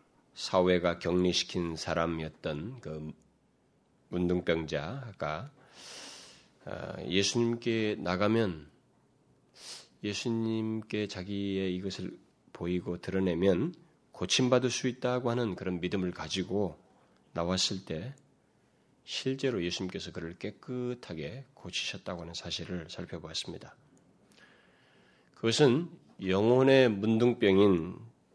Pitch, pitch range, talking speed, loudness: 95 Hz, 90-120 Hz, 220 characters per minute, -31 LUFS